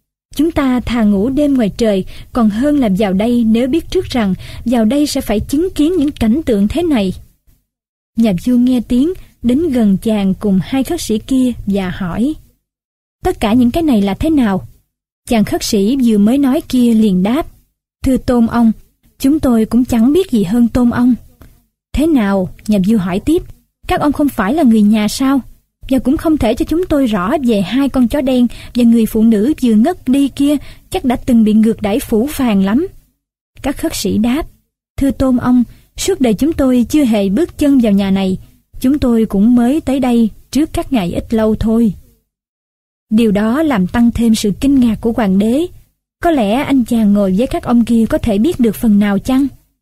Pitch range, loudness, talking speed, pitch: 220-280 Hz, -13 LUFS, 205 wpm, 245 Hz